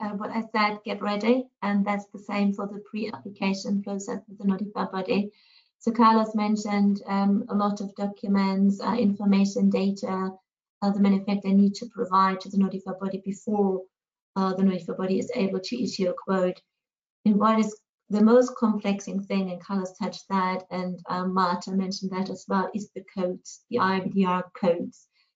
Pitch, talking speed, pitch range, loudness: 200 Hz, 175 wpm, 190-215 Hz, -26 LUFS